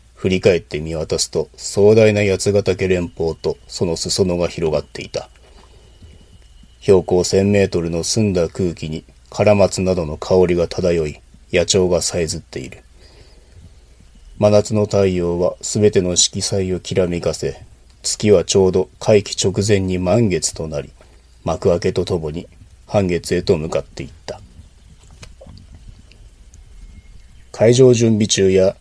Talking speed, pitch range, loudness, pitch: 245 characters per minute, 85-100 Hz, -17 LUFS, 95 Hz